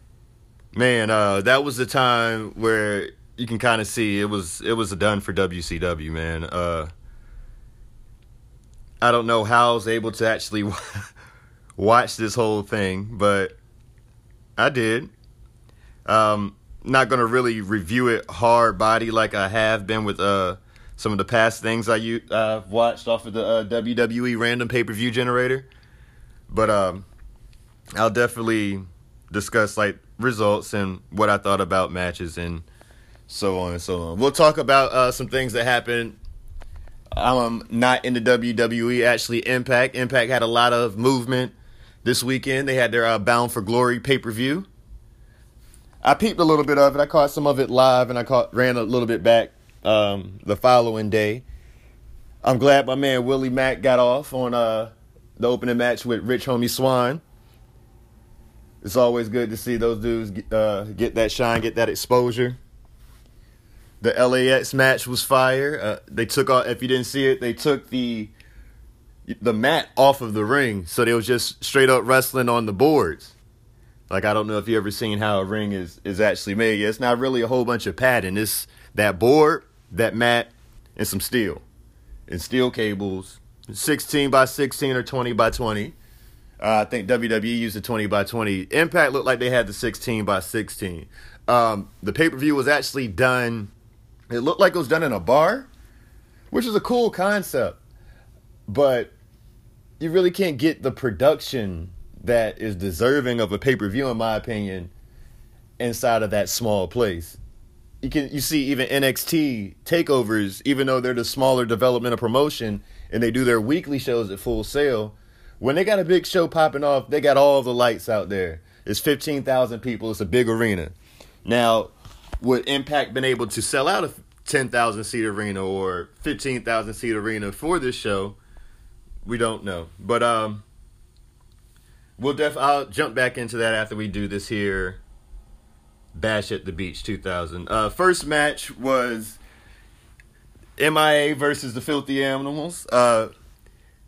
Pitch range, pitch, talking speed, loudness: 105-125 Hz, 115 Hz, 170 wpm, -21 LUFS